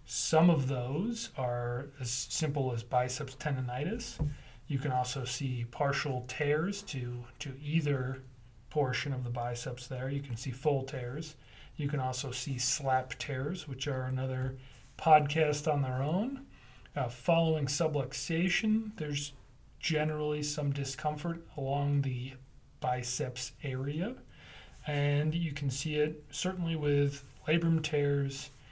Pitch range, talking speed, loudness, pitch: 130-150 Hz, 125 wpm, -33 LUFS, 140 Hz